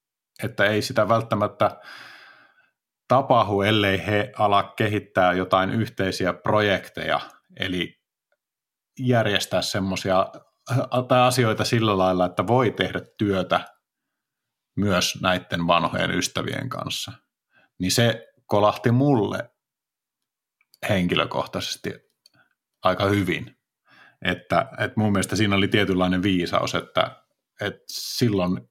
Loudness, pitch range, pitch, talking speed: -23 LUFS, 95-115 Hz, 100 Hz, 95 wpm